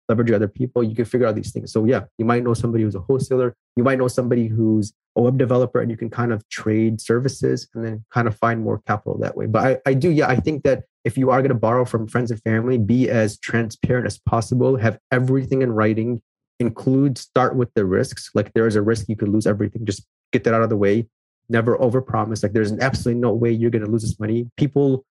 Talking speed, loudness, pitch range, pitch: 250 wpm, -20 LUFS, 110-125 Hz, 115 Hz